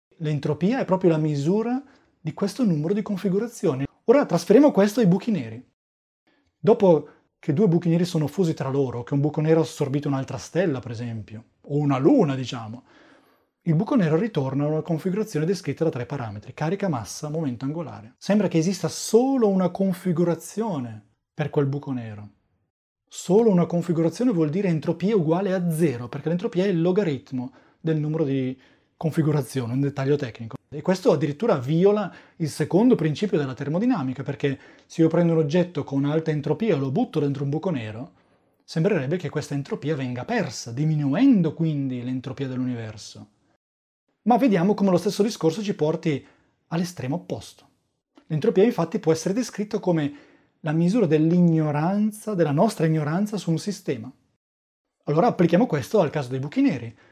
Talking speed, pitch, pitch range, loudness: 160 wpm, 155 Hz, 140-190 Hz, -23 LUFS